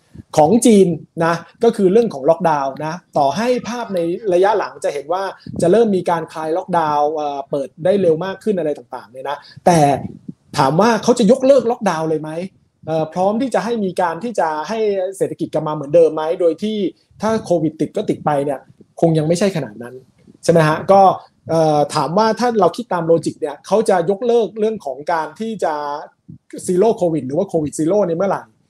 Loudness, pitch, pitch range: -17 LUFS, 170 Hz, 155-210 Hz